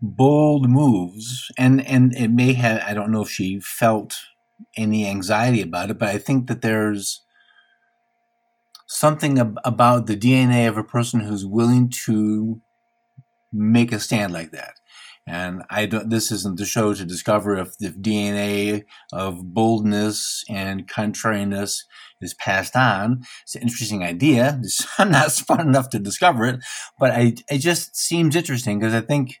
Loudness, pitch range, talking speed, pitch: -20 LUFS, 105-130 Hz, 155 wpm, 115 Hz